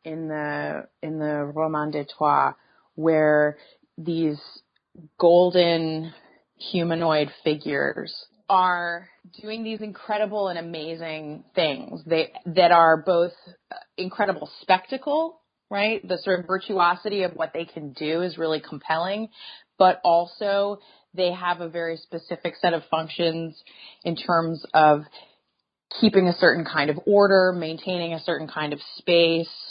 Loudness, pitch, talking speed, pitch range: -23 LUFS, 170 Hz, 125 wpm, 160-185 Hz